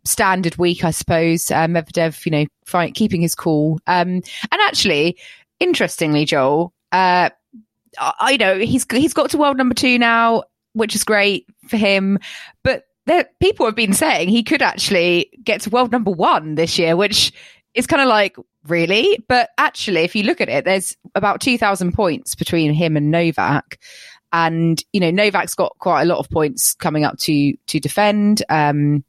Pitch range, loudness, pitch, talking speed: 165-225 Hz, -17 LUFS, 190 Hz, 180 wpm